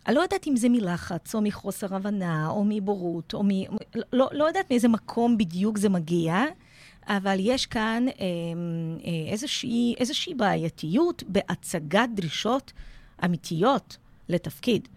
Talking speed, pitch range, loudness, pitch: 125 wpm, 175-240 Hz, -26 LUFS, 205 Hz